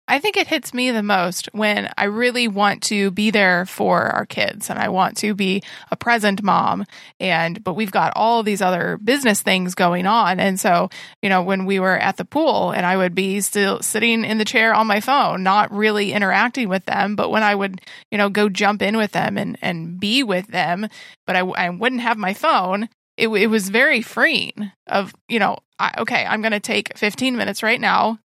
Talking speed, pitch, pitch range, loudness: 220 wpm, 205 Hz, 190-225 Hz, -18 LUFS